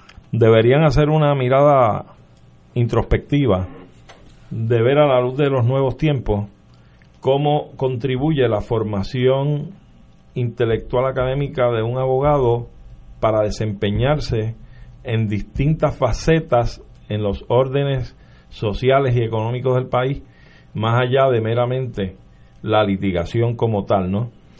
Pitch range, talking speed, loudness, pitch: 105-130 Hz, 110 wpm, -19 LUFS, 120 Hz